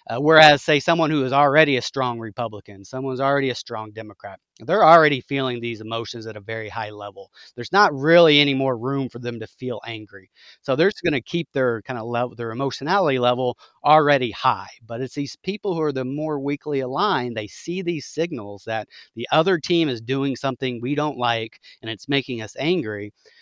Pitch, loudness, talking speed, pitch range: 130 Hz, -21 LUFS, 205 wpm, 115-150 Hz